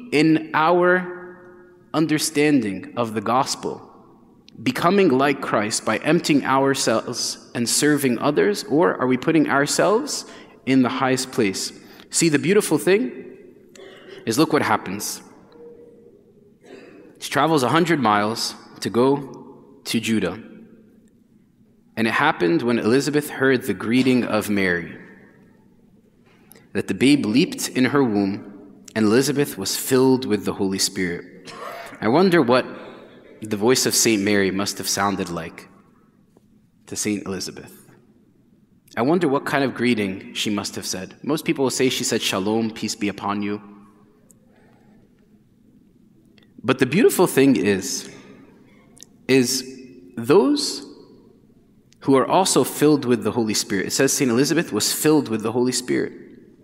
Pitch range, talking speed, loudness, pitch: 105-145 Hz, 135 wpm, -20 LUFS, 125 Hz